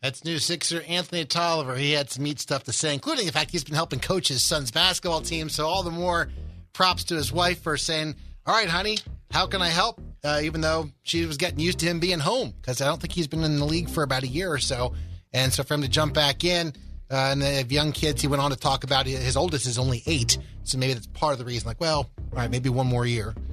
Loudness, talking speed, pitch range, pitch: -25 LUFS, 270 wpm, 130-165 Hz, 150 Hz